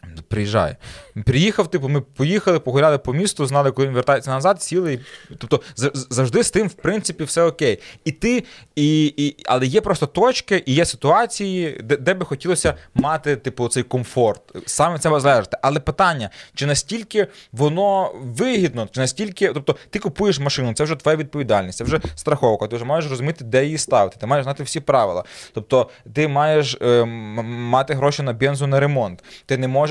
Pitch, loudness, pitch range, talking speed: 145 Hz, -19 LUFS, 130-170 Hz, 175 wpm